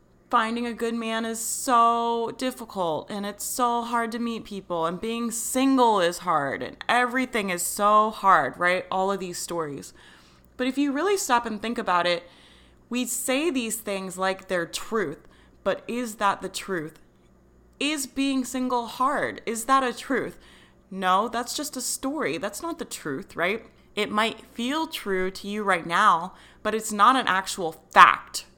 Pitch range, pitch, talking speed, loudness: 190-245 Hz, 225 Hz, 170 wpm, -25 LUFS